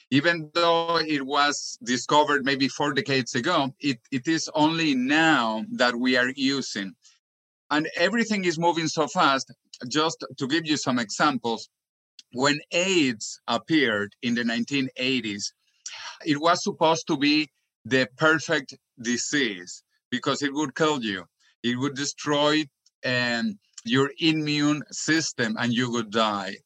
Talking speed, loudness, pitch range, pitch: 135 wpm, -24 LUFS, 125-160 Hz, 140 Hz